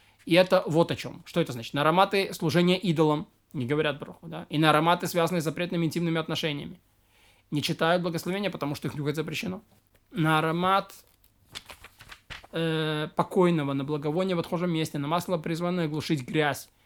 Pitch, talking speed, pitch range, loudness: 160 Hz, 165 wpm, 150-175 Hz, -27 LUFS